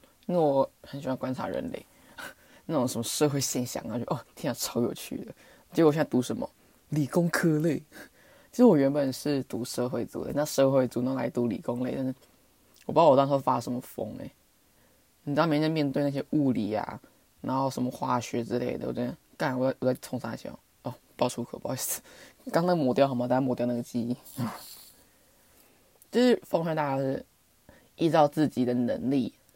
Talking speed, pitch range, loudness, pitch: 295 characters per minute, 125-150 Hz, -28 LUFS, 135 Hz